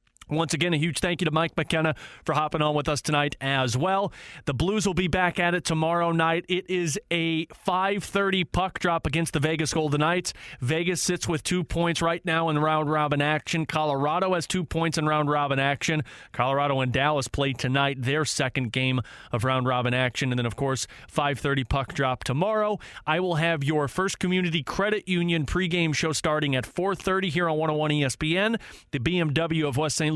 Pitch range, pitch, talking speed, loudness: 145-175 Hz, 160 Hz, 195 wpm, -25 LUFS